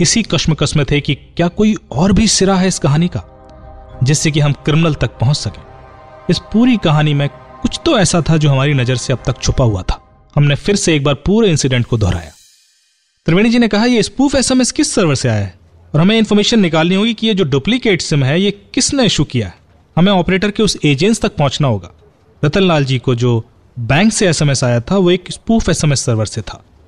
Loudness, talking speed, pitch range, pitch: -13 LUFS, 215 wpm, 130-195 Hz, 150 Hz